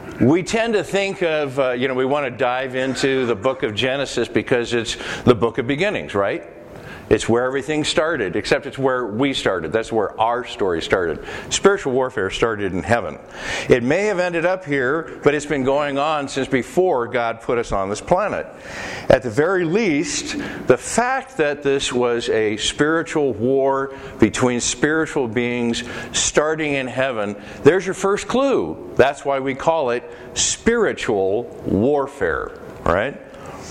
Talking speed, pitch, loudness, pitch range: 165 wpm, 135 Hz, -20 LUFS, 120-155 Hz